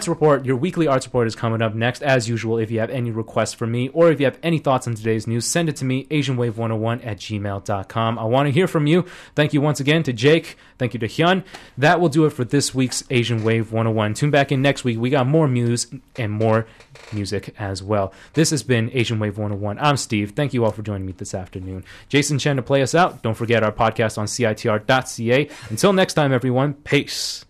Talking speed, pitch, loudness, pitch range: 235 wpm, 125 Hz, -20 LUFS, 110-145 Hz